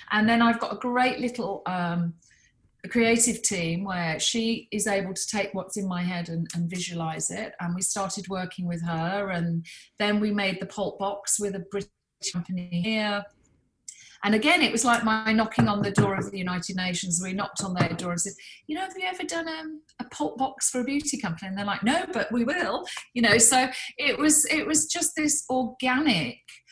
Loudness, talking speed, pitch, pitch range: -25 LUFS, 215 wpm, 205 Hz, 185-245 Hz